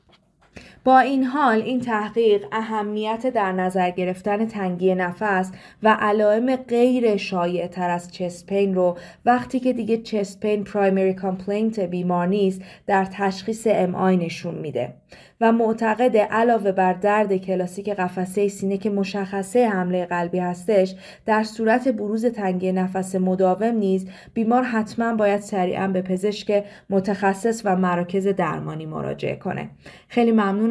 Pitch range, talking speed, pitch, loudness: 185-220 Hz, 130 wpm, 200 Hz, -22 LUFS